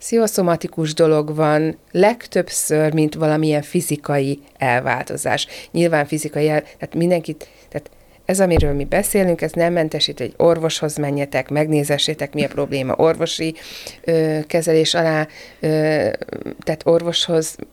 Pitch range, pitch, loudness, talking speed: 150-170 Hz, 155 Hz, -18 LUFS, 120 wpm